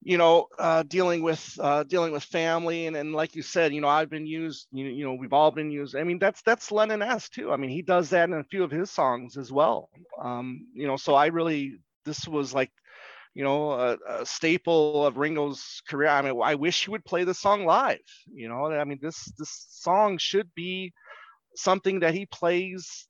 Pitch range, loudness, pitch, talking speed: 145-175 Hz, -26 LUFS, 160 Hz, 225 wpm